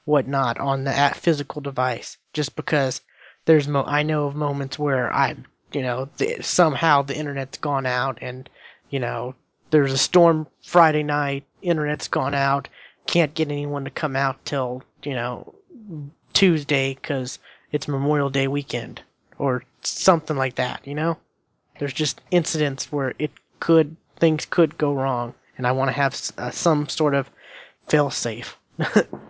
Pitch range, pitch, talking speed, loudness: 135-155 Hz, 140 Hz, 160 wpm, -22 LUFS